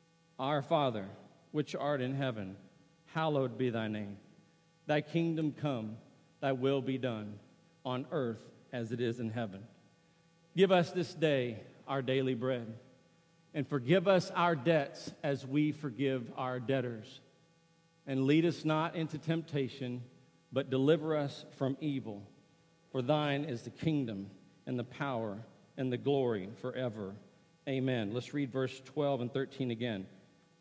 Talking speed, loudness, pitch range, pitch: 140 wpm, -35 LUFS, 125-165 Hz, 135 Hz